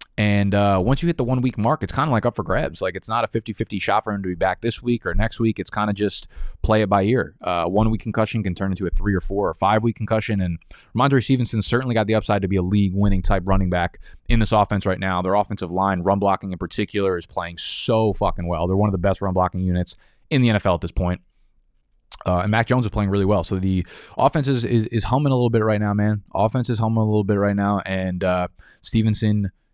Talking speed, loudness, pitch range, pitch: 270 wpm, -21 LUFS, 95-110 Hz, 100 Hz